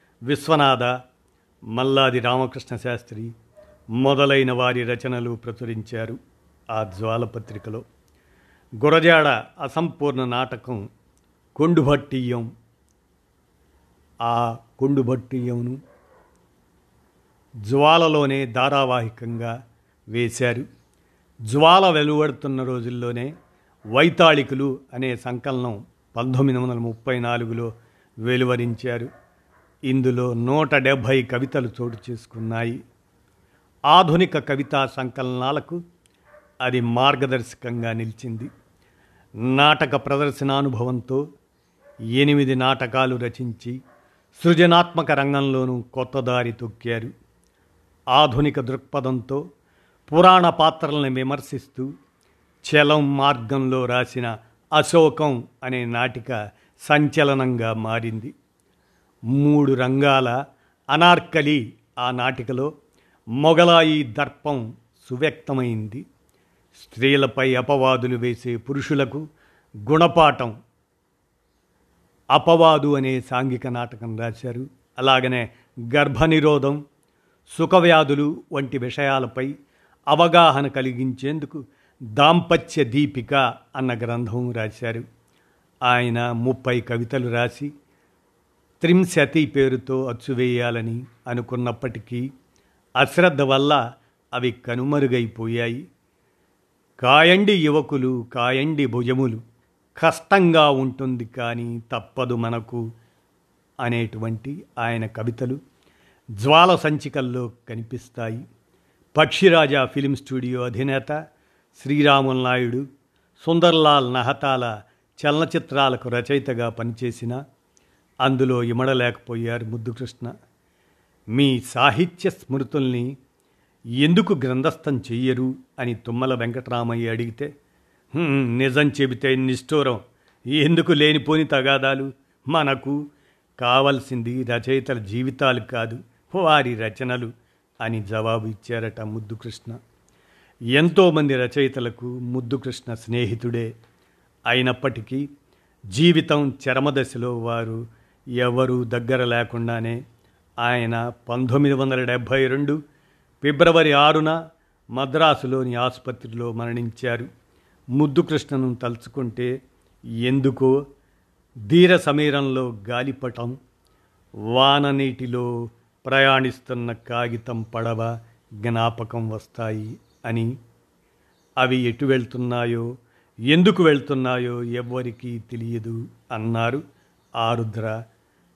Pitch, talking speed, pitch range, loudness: 125 Hz, 70 wpm, 120-140 Hz, -21 LUFS